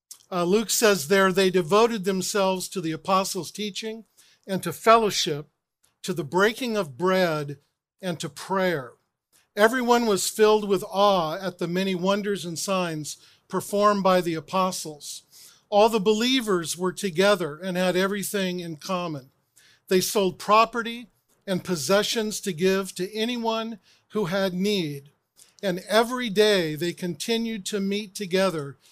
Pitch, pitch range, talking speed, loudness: 190 Hz, 175-210 Hz, 140 wpm, -24 LUFS